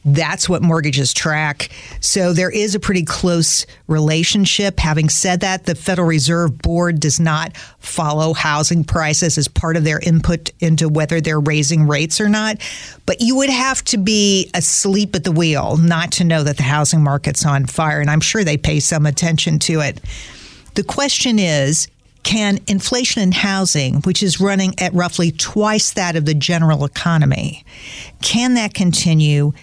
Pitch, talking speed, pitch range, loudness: 165 Hz, 170 wpm, 155-190 Hz, -15 LUFS